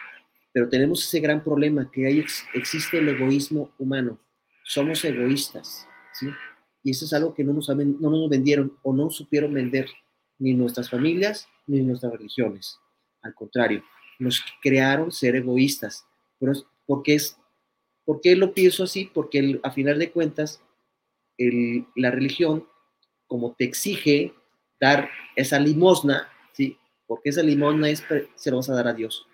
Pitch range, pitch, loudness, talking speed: 125-150 Hz, 140 Hz, -23 LUFS, 150 wpm